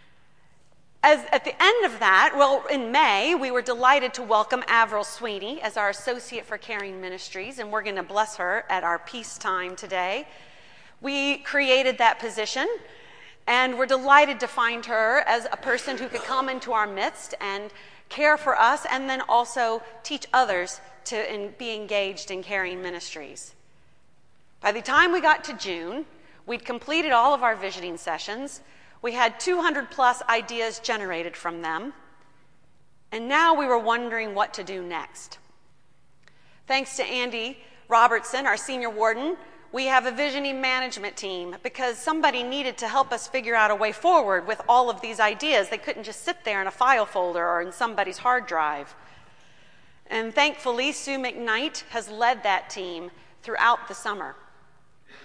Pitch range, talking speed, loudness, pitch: 200-265 Hz, 165 wpm, -24 LUFS, 235 Hz